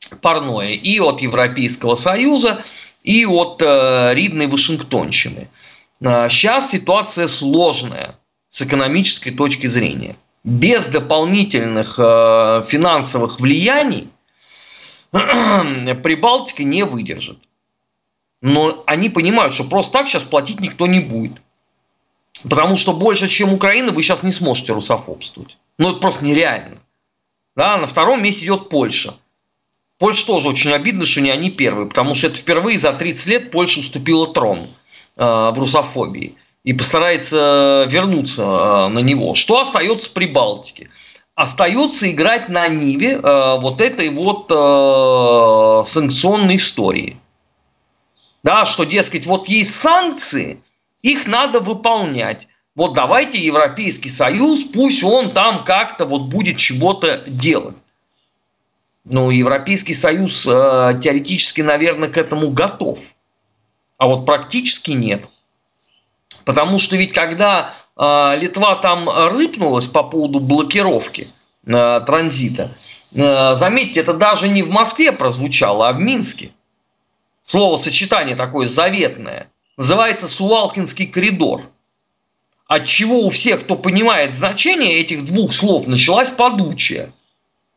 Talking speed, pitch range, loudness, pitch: 115 wpm, 135-200 Hz, -14 LUFS, 165 Hz